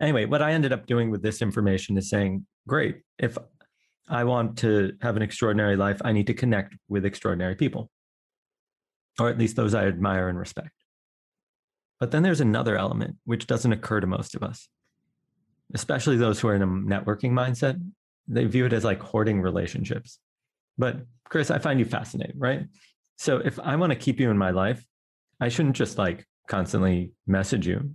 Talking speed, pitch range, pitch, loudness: 185 wpm, 100-125 Hz, 110 Hz, -26 LUFS